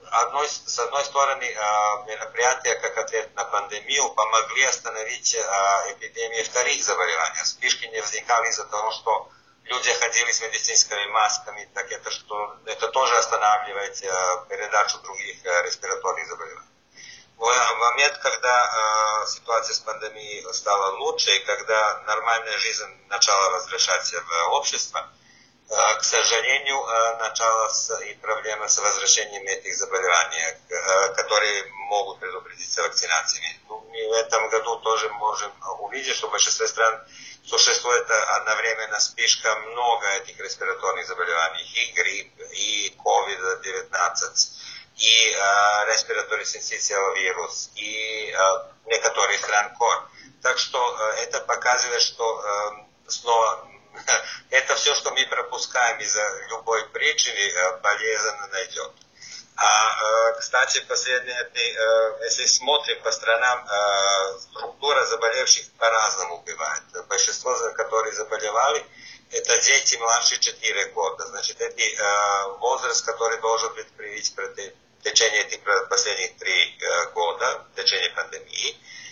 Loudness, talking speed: -22 LUFS, 110 wpm